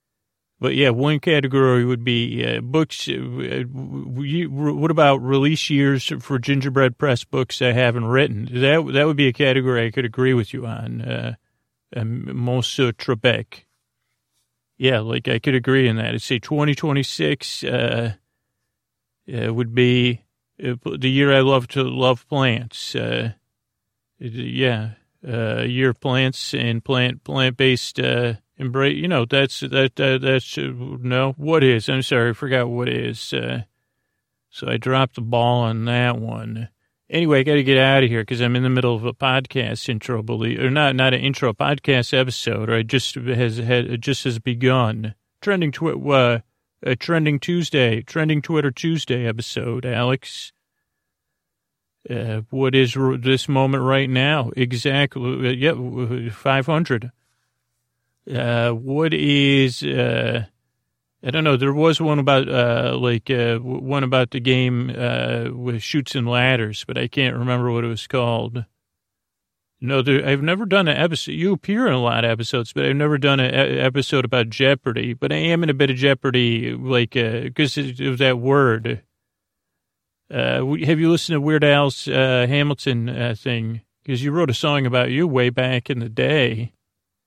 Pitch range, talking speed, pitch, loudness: 120-140 Hz, 170 wpm, 125 Hz, -20 LUFS